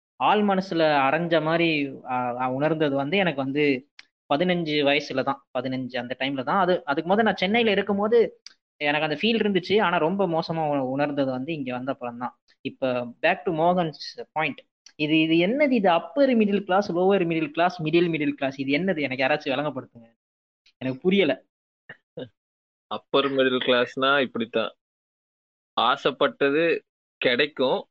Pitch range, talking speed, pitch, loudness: 130-180 Hz, 135 wpm, 150 Hz, -24 LUFS